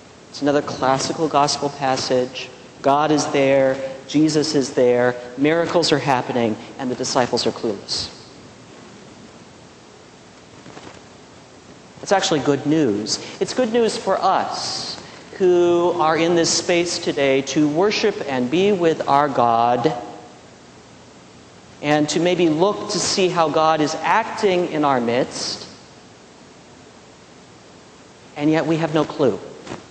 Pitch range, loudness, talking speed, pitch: 130-170 Hz, -19 LUFS, 120 wpm, 150 Hz